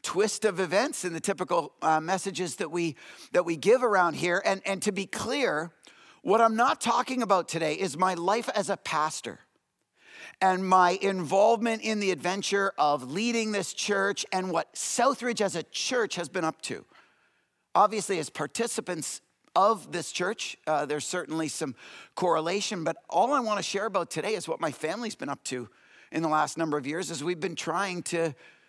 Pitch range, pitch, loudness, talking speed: 165-210 Hz, 185 Hz, -28 LUFS, 185 wpm